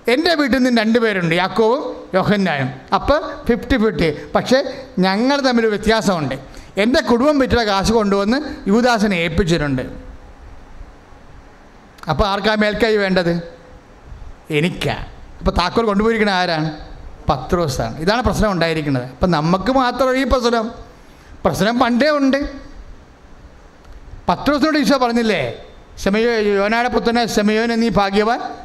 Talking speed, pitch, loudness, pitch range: 110 wpm, 210 Hz, -17 LUFS, 160-240 Hz